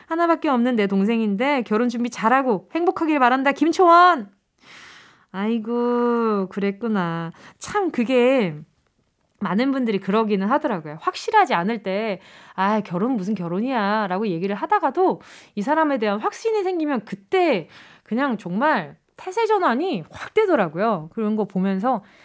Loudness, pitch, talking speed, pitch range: -21 LUFS, 230 Hz, 300 characters per minute, 200-290 Hz